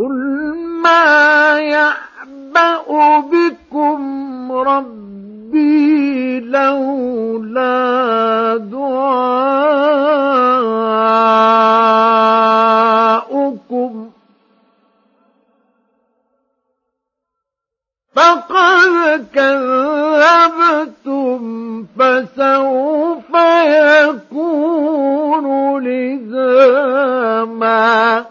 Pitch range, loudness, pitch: 230-300 Hz, -12 LUFS, 270 Hz